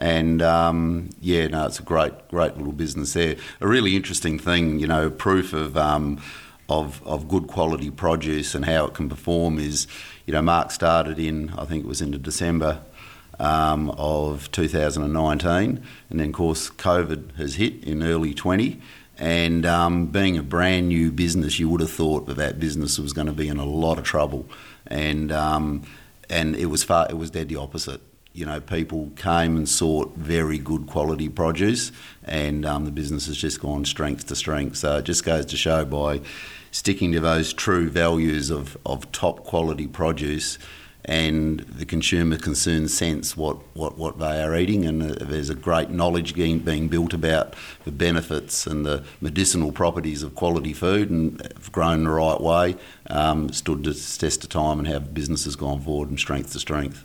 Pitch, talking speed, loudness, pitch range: 80 Hz, 190 wpm, -23 LUFS, 75-85 Hz